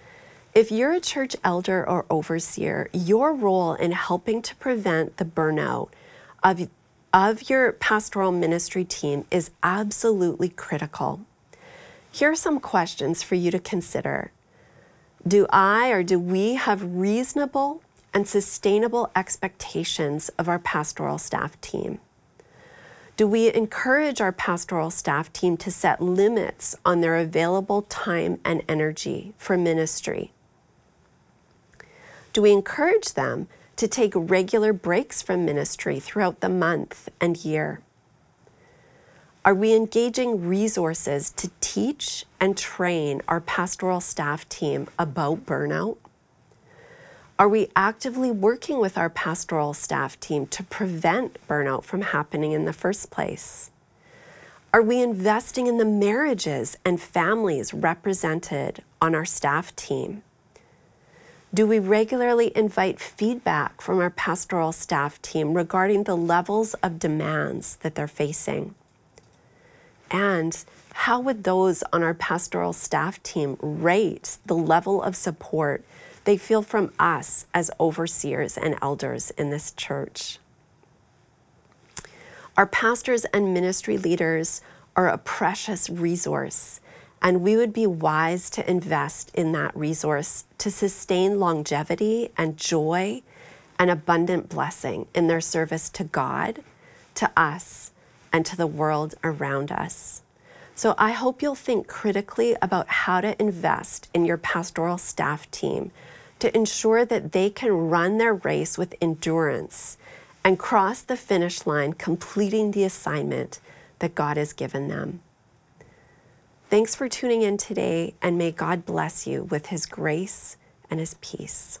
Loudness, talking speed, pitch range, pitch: -24 LUFS, 130 wpm, 165-215 Hz, 180 Hz